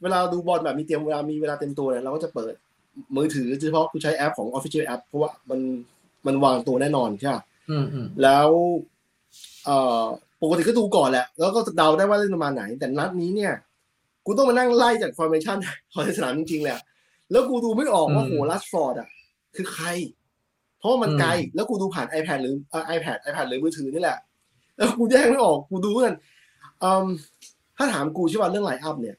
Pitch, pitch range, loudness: 160 Hz, 140-195 Hz, -23 LUFS